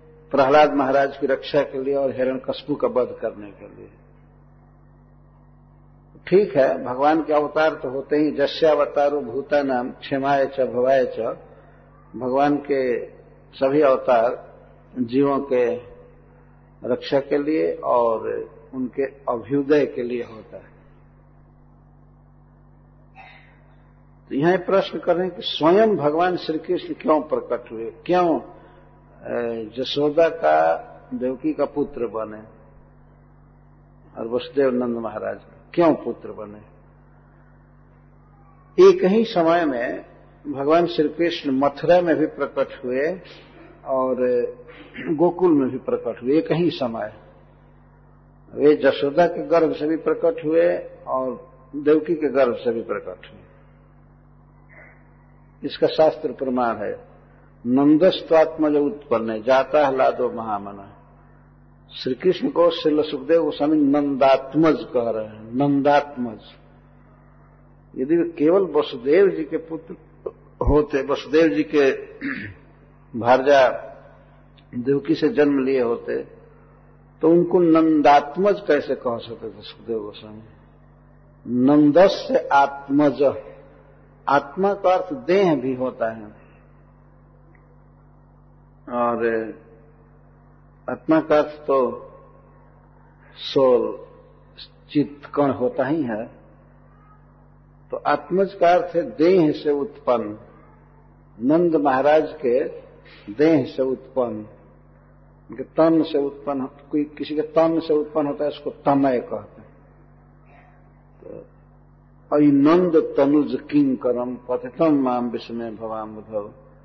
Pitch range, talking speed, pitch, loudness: 125-160 Hz, 105 wpm, 140 Hz, -20 LUFS